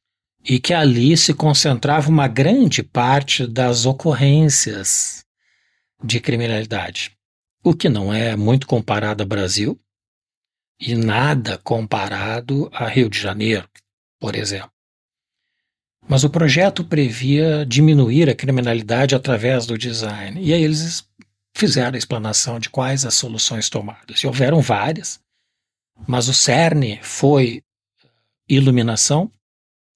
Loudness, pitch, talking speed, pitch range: -17 LUFS, 125 Hz, 115 wpm, 110-145 Hz